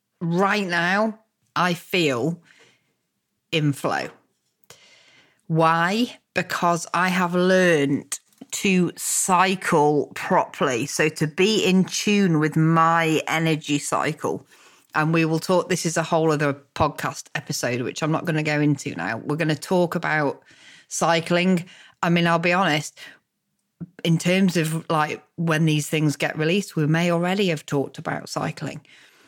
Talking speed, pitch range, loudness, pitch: 140 wpm, 155-180 Hz, -22 LUFS, 165 Hz